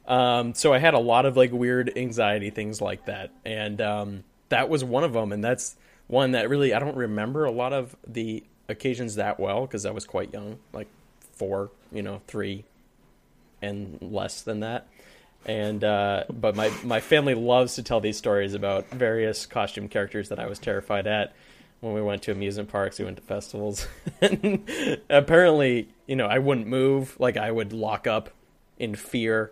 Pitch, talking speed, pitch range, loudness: 110 Hz, 190 wpm, 105-125 Hz, -25 LUFS